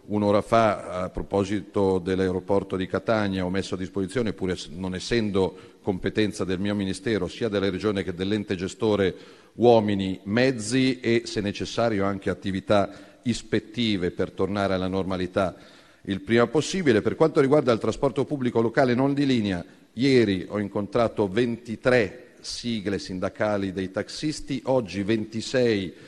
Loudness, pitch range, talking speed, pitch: -25 LUFS, 95-115 Hz, 135 wpm, 105 Hz